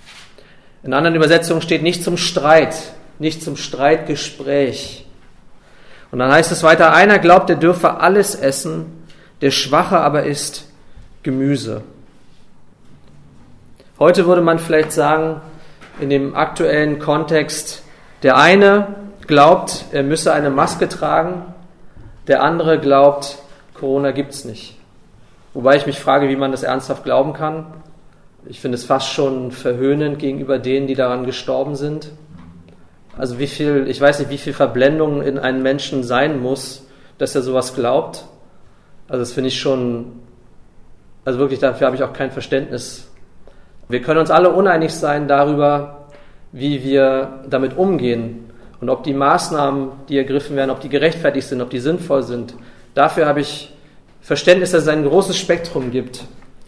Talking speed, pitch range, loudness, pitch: 145 wpm, 130-155 Hz, -16 LUFS, 140 Hz